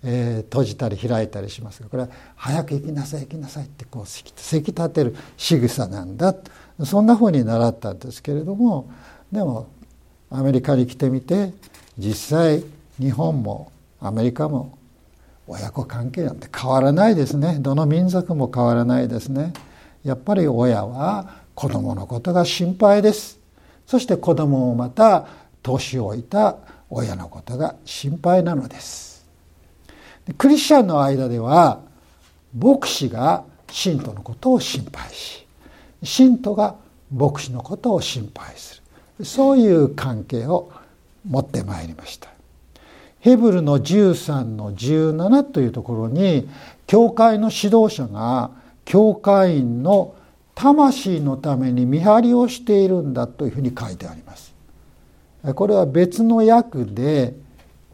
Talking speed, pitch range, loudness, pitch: 270 characters per minute, 120-185 Hz, -19 LUFS, 140 Hz